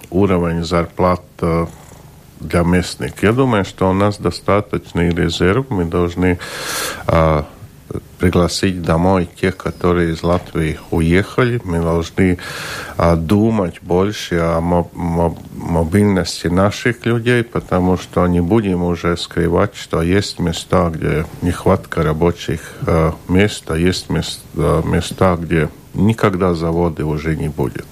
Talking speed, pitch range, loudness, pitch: 115 wpm, 85-95 Hz, -17 LUFS, 90 Hz